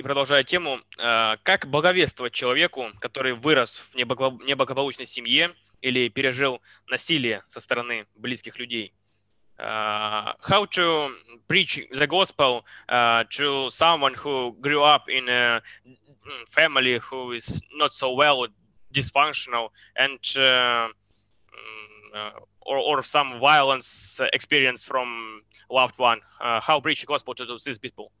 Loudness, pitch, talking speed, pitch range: -22 LUFS, 125 Hz, 115 wpm, 115-140 Hz